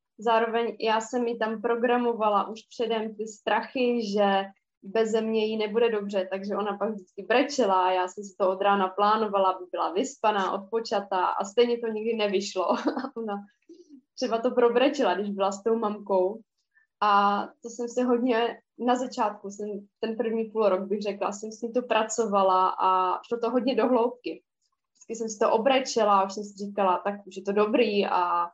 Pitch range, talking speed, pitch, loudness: 200-235 Hz, 185 wpm, 220 Hz, -26 LUFS